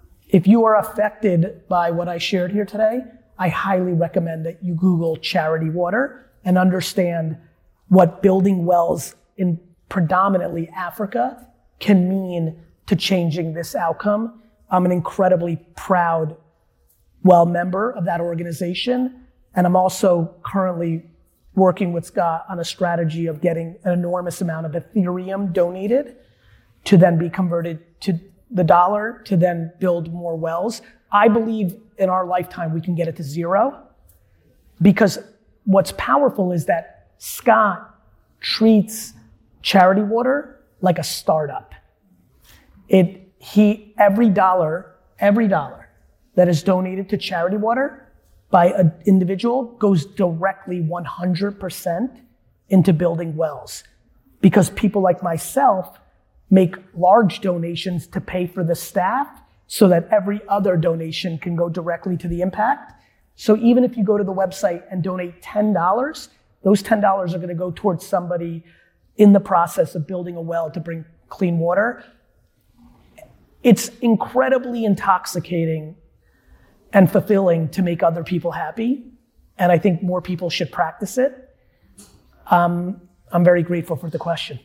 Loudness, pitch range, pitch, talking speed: -19 LUFS, 170-205 Hz, 185 Hz, 135 wpm